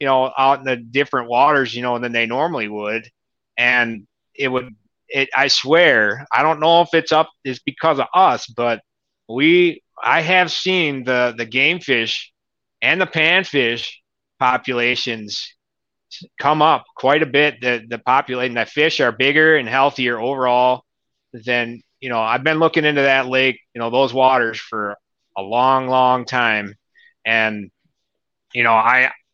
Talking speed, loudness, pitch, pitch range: 160 wpm, -17 LUFS, 130 Hz, 120-150 Hz